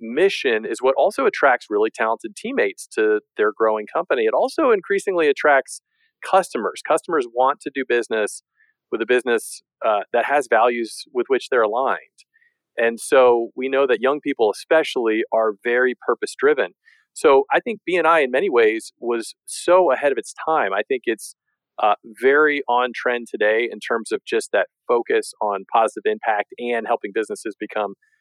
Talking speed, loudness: 170 wpm, -20 LUFS